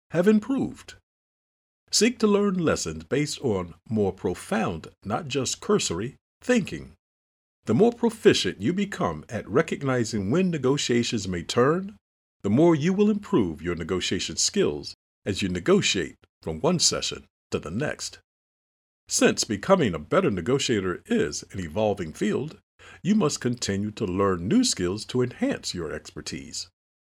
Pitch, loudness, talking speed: 120 Hz, -25 LUFS, 140 wpm